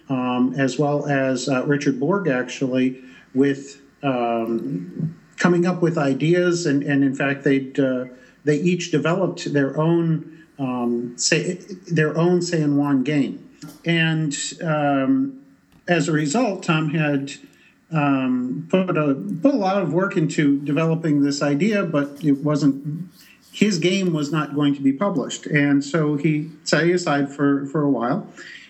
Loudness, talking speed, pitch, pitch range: -21 LUFS, 150 wpm, 150 Hz, 140-170 Hz